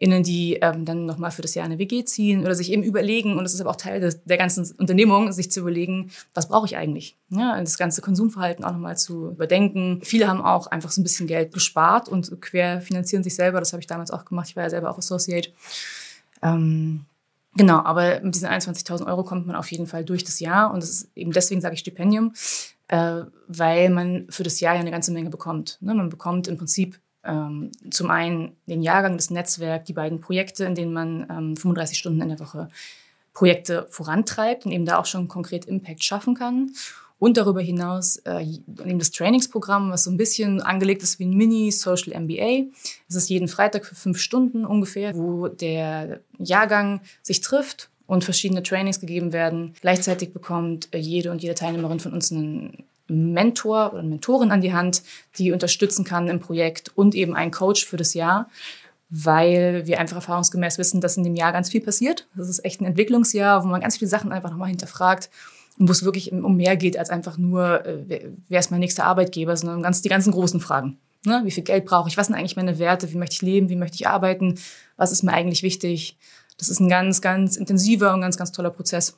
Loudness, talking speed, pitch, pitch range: -21 LUFS, 210 wpm, 180 Hz, 170-195 Hz